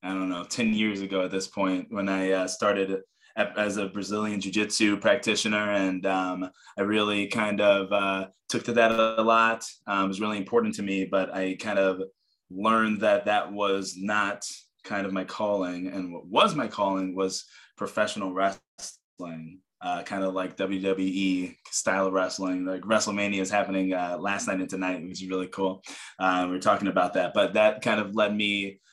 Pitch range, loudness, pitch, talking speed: 95-105 Hz, -26 LUFS, 95 Hz, 190 wpm